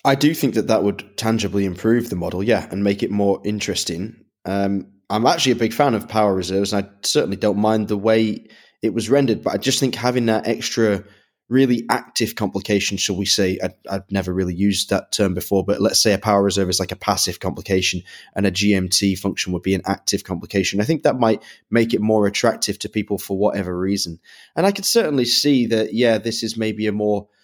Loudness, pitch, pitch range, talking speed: -20 LUFS, 105 Hz, 95-115 Hz, 225 wpm